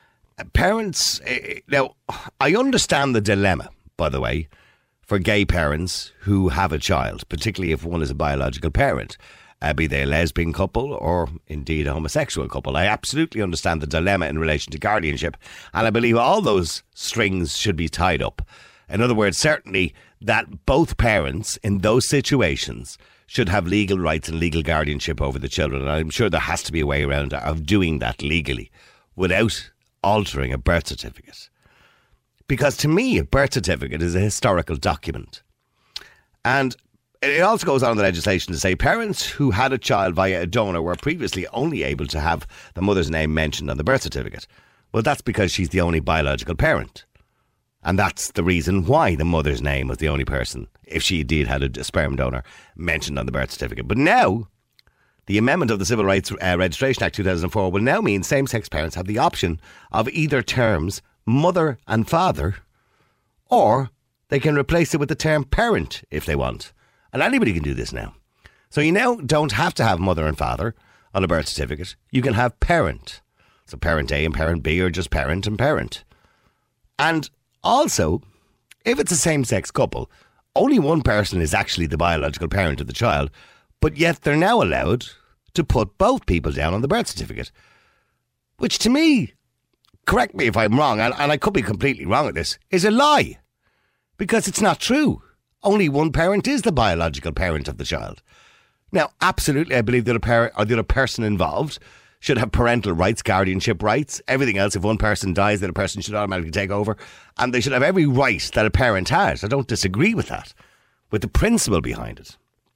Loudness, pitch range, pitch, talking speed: -21 LUFS, 80-125 Hz, 95 Hz, 190 wpm